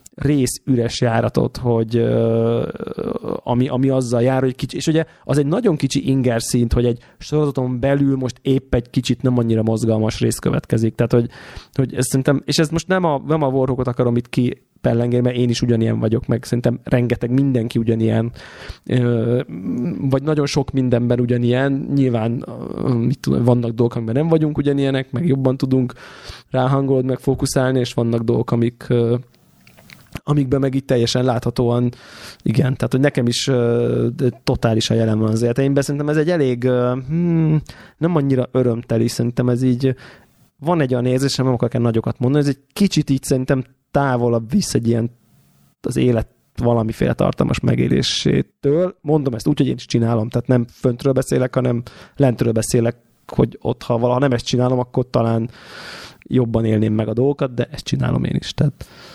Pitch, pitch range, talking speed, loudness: 125 Hz, 120-140 Hz, 170 wpm, -19 LUFS